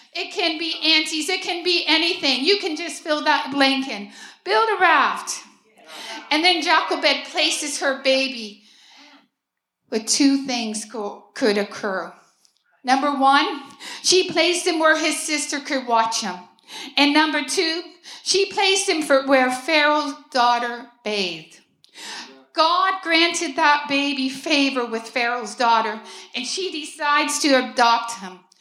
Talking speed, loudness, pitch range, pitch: 135 wpm, -19 LUFS, 240-330 Hz, 290 Hz